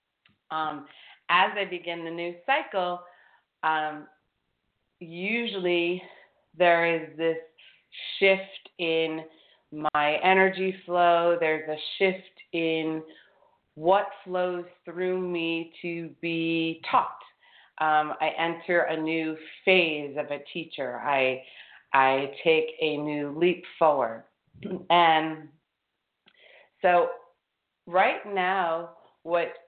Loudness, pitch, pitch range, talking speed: -26 LUFS, 165 Hz, 155-180 Hz, 100 wpm